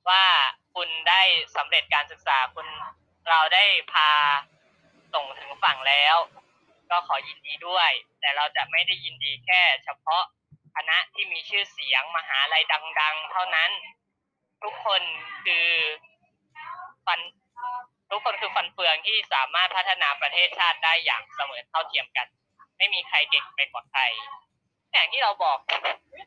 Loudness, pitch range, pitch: -22 LUFS, 155-185 Hz, 165 Hz